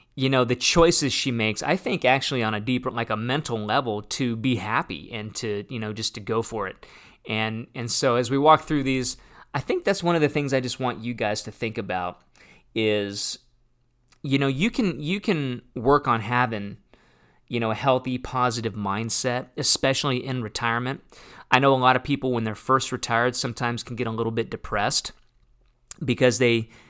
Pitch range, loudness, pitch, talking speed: 115-130 Hz, -24 LUFS, 125 Hz, 200 wpm